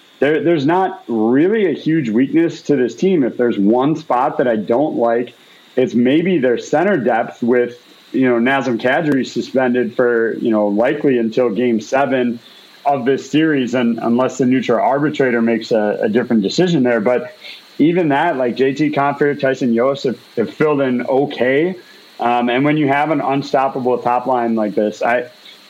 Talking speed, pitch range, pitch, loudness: 175 wpm, 120-140 Hz, 130 Hz, -16 LUFS